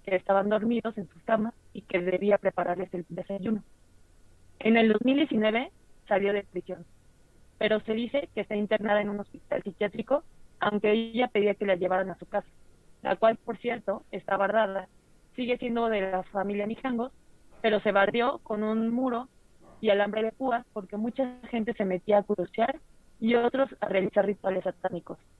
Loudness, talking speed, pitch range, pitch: -28 LUFS, 170 wpm, 195-230 Hz, 210 Hz